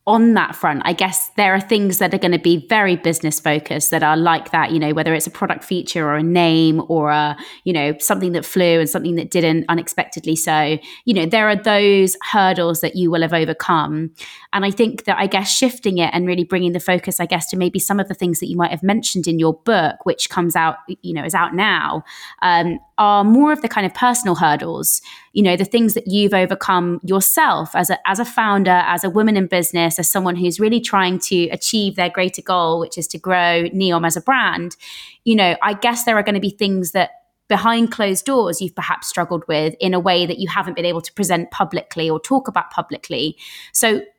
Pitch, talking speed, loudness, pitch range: 180 Hz, 230 wpm, -17 LUFS, 170-200 Hz